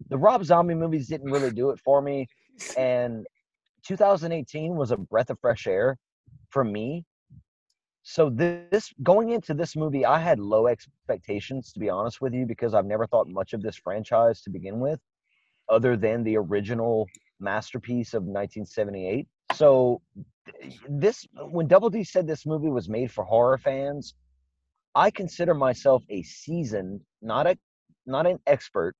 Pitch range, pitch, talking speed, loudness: 115-165 Hz, 135 Hz, 155 wpm, -25 LUFS